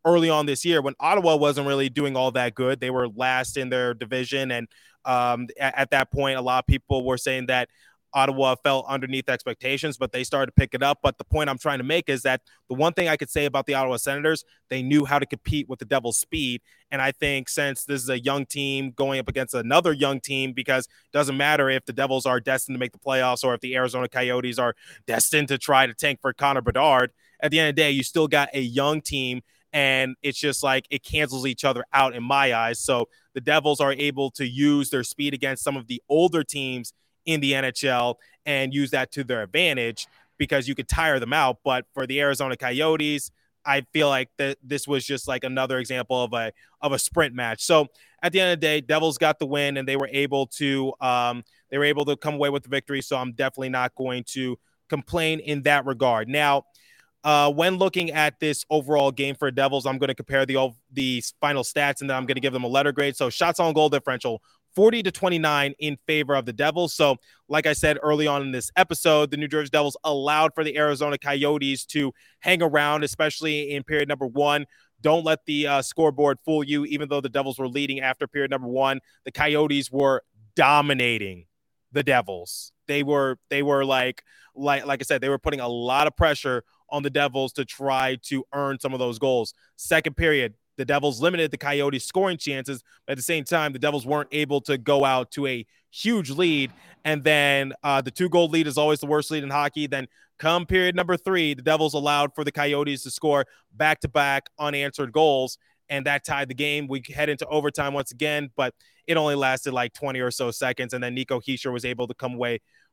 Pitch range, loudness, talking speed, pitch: 130-150 Hz, -23 LUFS, 225 wpm, 140 Hz